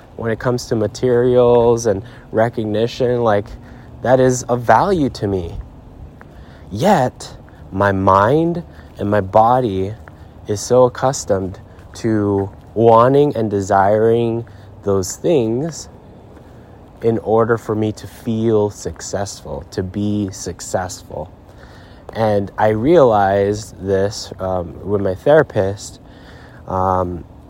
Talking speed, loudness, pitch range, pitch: 105 wpm, -17 LUFS, 95-115 Hz, 105 Hz